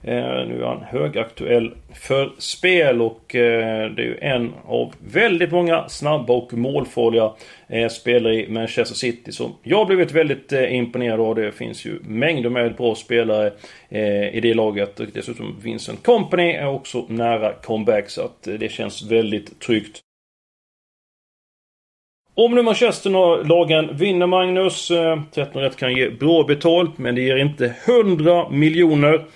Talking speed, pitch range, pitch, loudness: 140 wpm, 115-165 Hz, 125 Hz, -19 LUFS